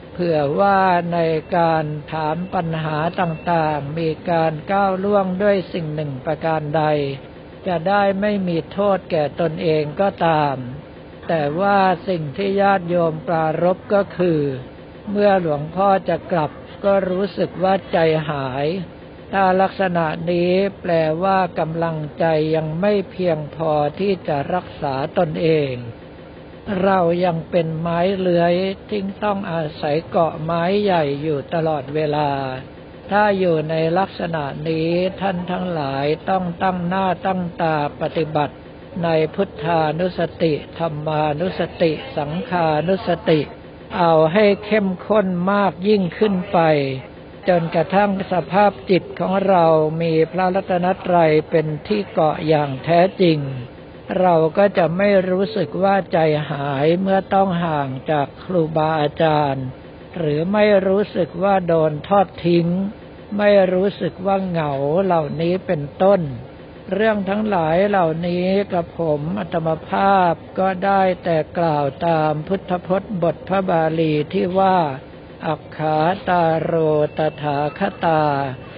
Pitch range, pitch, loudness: 155-190 Hz, 170 Hz, -19 LUFS